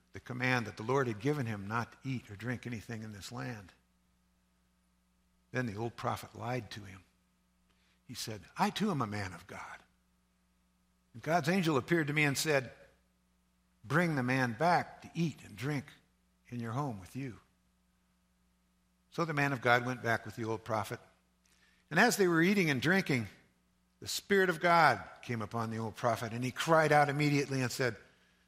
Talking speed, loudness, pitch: 185 wpm, -33 LUFS, 115 Hz